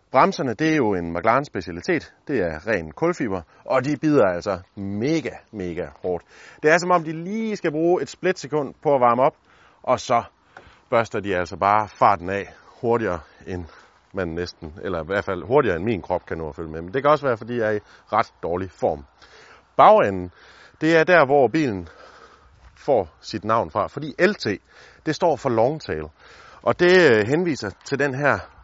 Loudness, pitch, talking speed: -22 LUFS, 120 Hz, 195 wpm